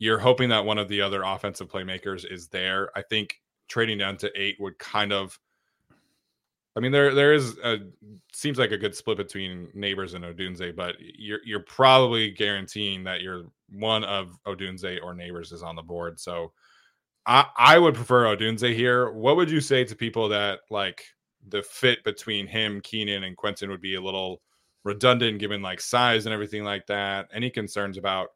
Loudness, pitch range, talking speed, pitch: -24 LUFS, 95-110 Hz, 185 wpm, 100 Hz